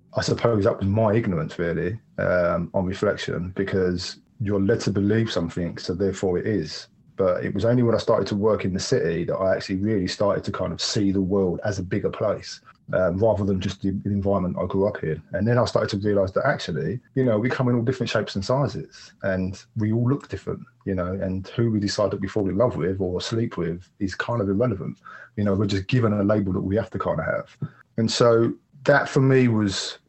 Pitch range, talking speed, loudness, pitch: 95-115 Hz, 235 wpm, -24 LUFS, 100 Hz